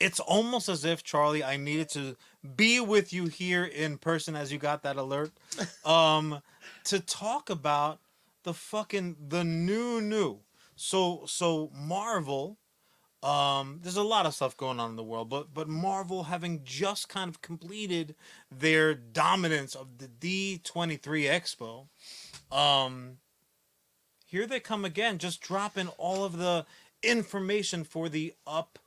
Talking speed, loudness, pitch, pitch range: 145 wpm, -30 LUFS, 165 Hz, 150-195 Hz